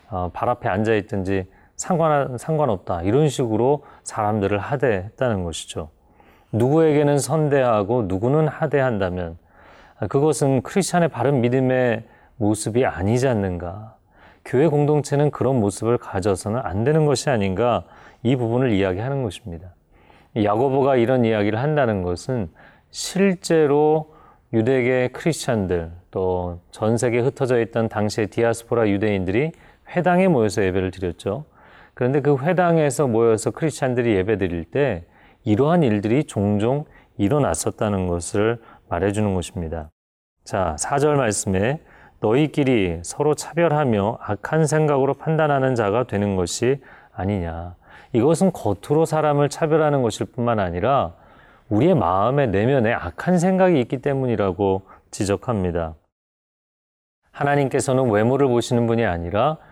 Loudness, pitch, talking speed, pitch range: -21 LUFS, 120 Hz, 310 characters per minute, 100-145 Hz